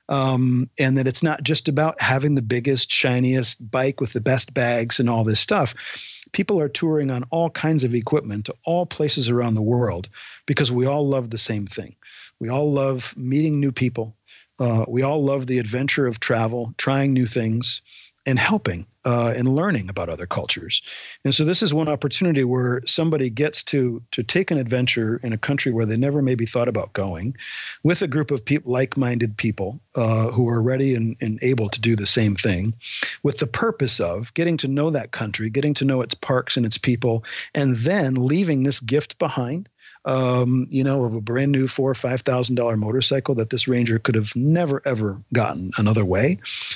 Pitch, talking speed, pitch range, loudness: 125 Hz, 200 wpm, 115-140 Hz, -21 LUFS